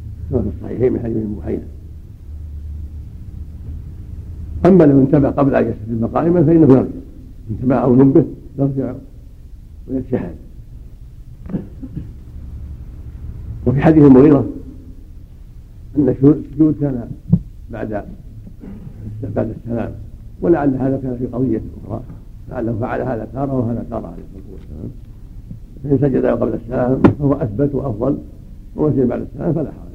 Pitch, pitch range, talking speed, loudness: 115 Hz, 85-135 Hz, 110 wpm, -16 LUFS